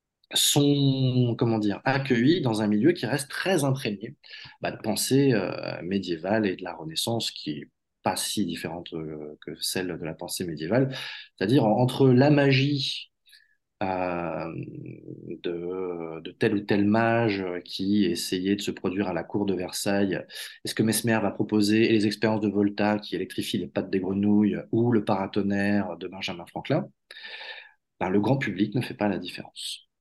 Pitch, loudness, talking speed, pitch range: 105 Hz, -26 LUFS, 170 wpm, 100-130 Hz